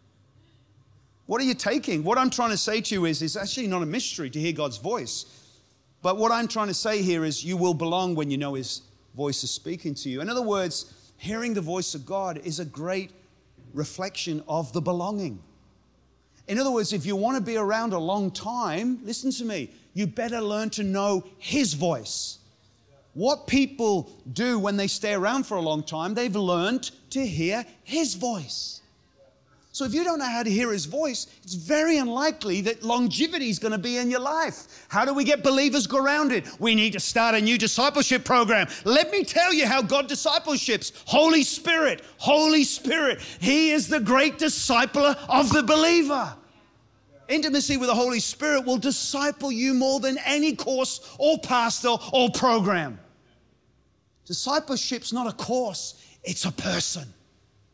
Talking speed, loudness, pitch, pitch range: 180 wpm, -24 LUFS, 220 Hz, 170-265 Hz